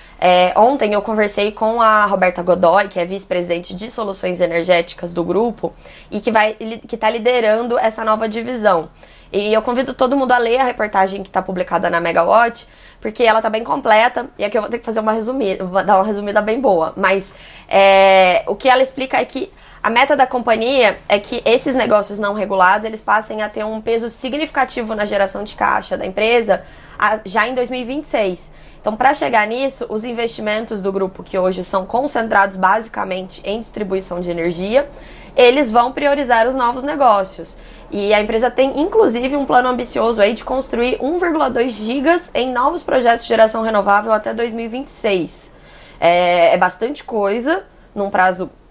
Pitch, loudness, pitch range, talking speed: 220 Hz, -16 LUFS, 195-245 Hz, 170 wpm